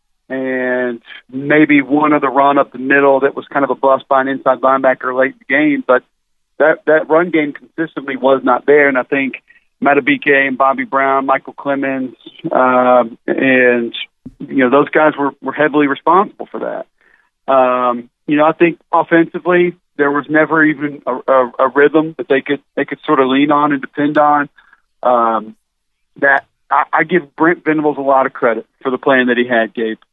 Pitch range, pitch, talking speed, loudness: 130-150 Hz, 140 Hz, 195 wpm, -13 LUFS